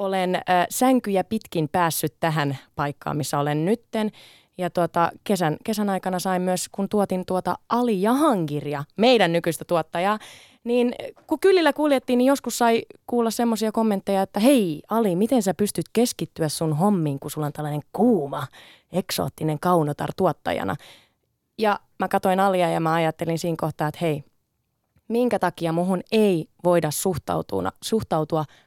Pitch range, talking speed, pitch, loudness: 160-220 Hz, 145 wpm, 180 Hz, -23 LUFS